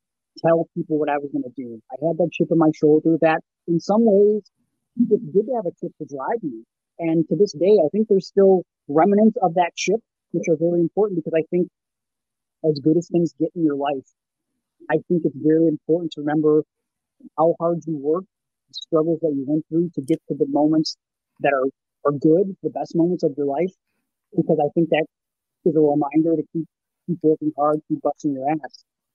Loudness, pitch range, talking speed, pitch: -21 LUFS, 150-170 Hz, 210 wpm, 160 Hz